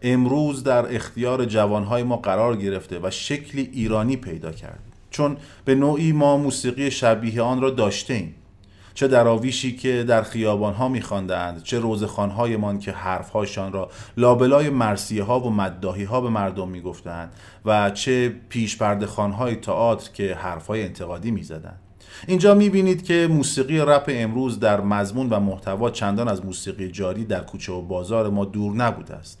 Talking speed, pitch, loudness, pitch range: 150 wpm, 110 Hz, -22 LUFS, 100-125 Hz